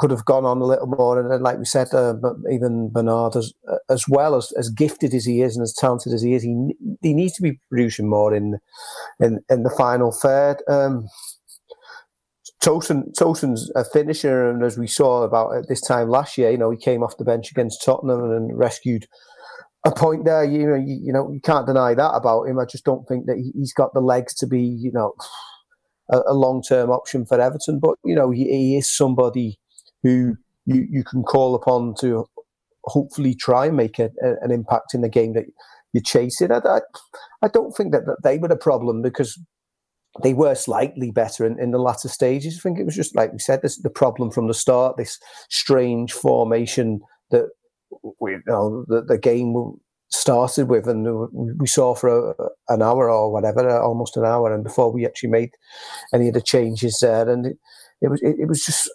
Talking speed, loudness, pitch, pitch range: 210 wpm, -20 LUFS, 125 Hz, 120-145 Hz